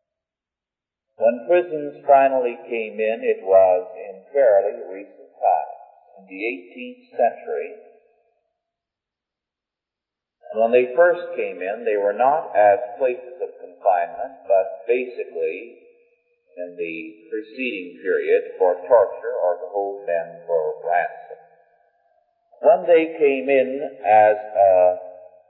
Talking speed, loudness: 115 wpm, -20 LUFS